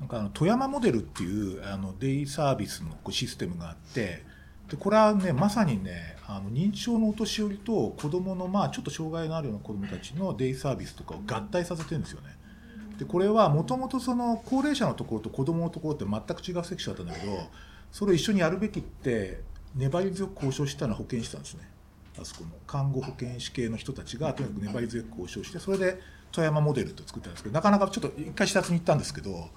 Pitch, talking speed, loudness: 140 Hz, 470 characters per minute, -29 LUFS